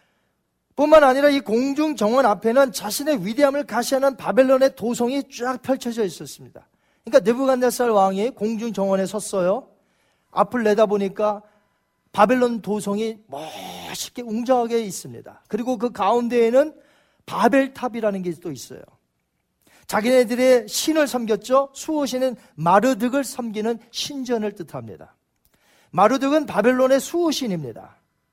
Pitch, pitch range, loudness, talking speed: 235 Hz, 205-265 Hz, -20 LUFS, 305 characters per minute